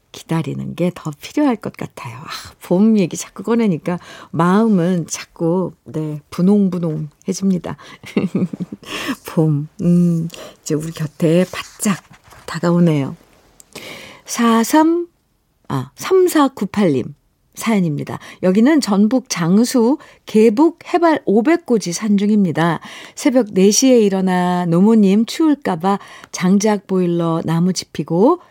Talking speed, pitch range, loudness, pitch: 215 characters per minute, 170-225 Hz, -17 LUFS, 190 Hz